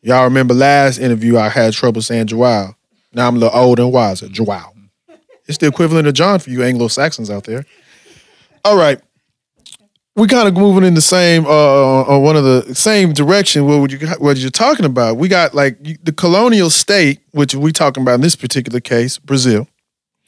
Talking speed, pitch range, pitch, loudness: 190 wpm, 120-160 Hz, 140 Hz, -12 LUFS